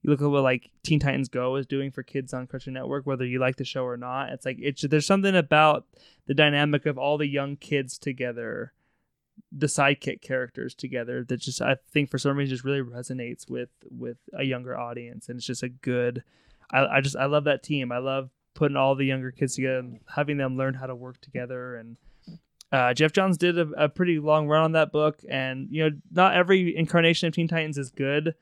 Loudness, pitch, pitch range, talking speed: -25 LUFS, 135 Hz, 130-150 Hz, 225 wpm